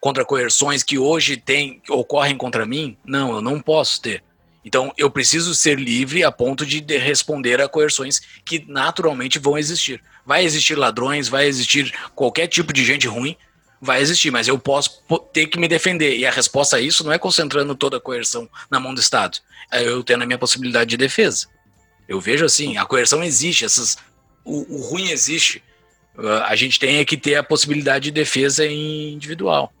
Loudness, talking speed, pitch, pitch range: -17 LUFS, 185 wpm, 140 Hz, 130-155 Hz